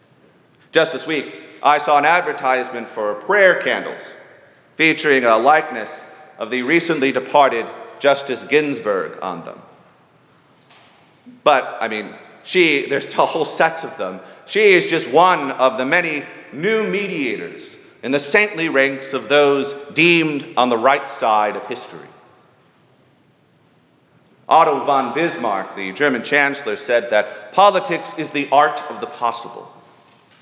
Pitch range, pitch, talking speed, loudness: 130-170 Hz, 145 Hz, 135 wpm, -17 LUFS